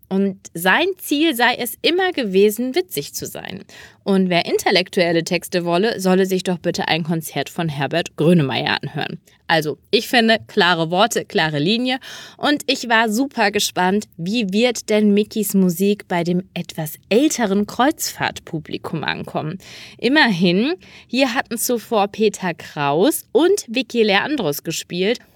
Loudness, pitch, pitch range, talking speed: -18 LUFS, 205 Hz, 175-240 Hz, 135 wpm